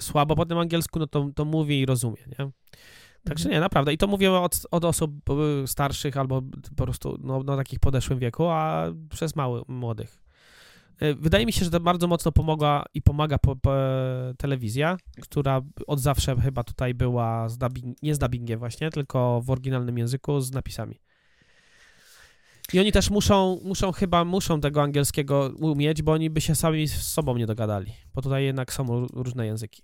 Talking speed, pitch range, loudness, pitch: 180 wpm, 125-155 Hz, -25 LUFS, 140 Hz